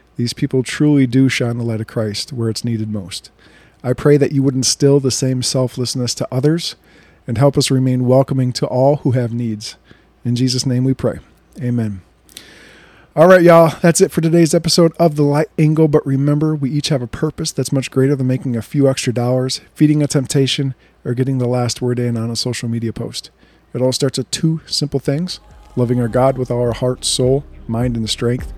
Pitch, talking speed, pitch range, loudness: 130 Hz, 210 wpm, 120-145 Hz, -16 LUFS